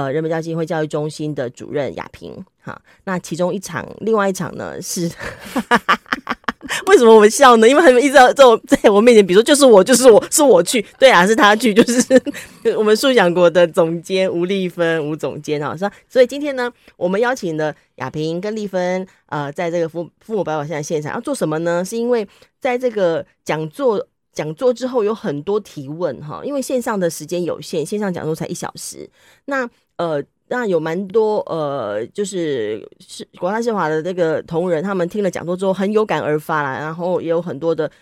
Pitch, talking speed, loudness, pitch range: 190 Hz, 305 characters per minute, -16 LUFS, 165-240 Hz